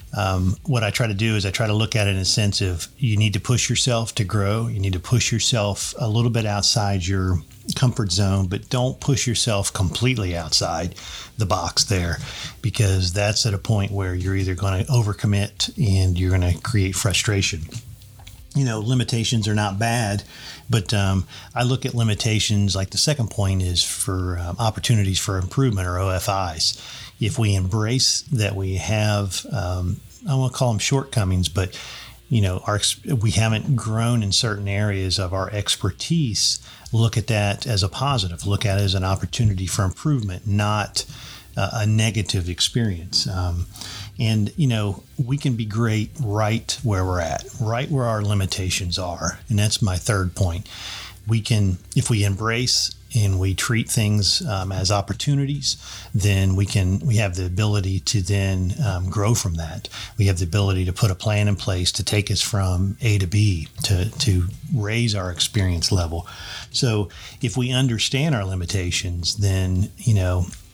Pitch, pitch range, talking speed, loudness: 105 Hz, 95-115 Hz, 175 wpm, -21 LUFS